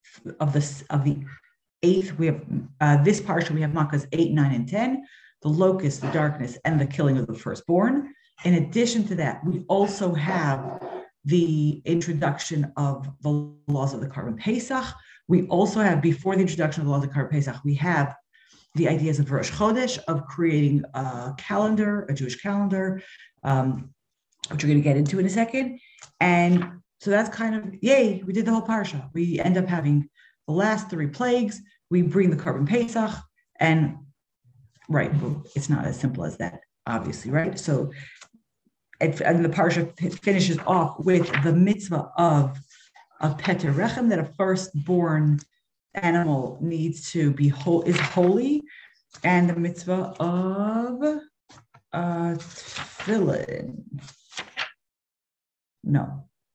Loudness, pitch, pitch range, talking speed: -24 LUFS, 170 Hz, 145-195 Hz, 150 wpm